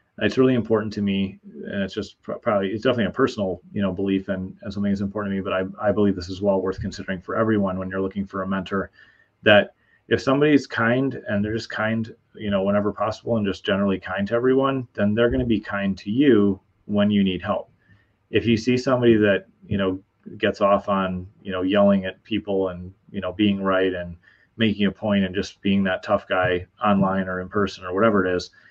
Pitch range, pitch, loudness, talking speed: 95-110 Hz, 100 Hz, -22 LUFS, 225 wpm